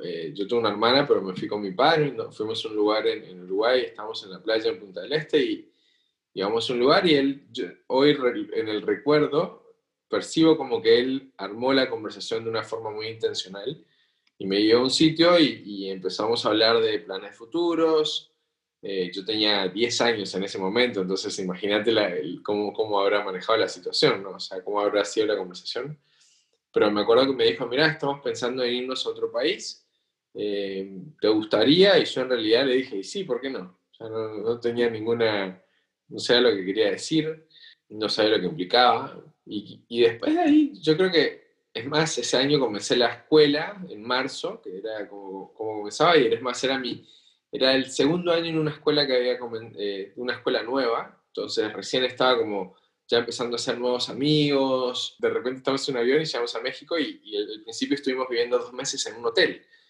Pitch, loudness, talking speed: 150 Hz, -24 LUFS, 200 wpm